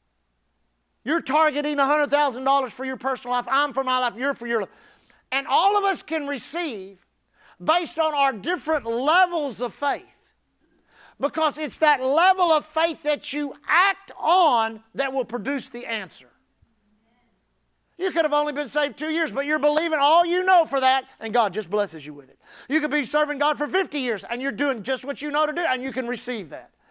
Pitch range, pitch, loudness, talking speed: 240-310 Hz, 280 Hz, -23 LUFS, 195 wpm